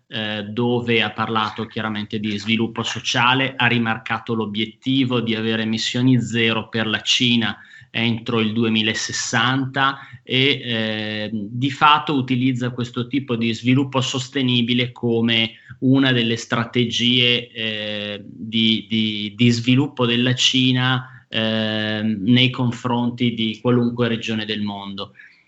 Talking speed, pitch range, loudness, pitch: 115 wpm, 110-125 Hz, -19 LUFS, 115 Hz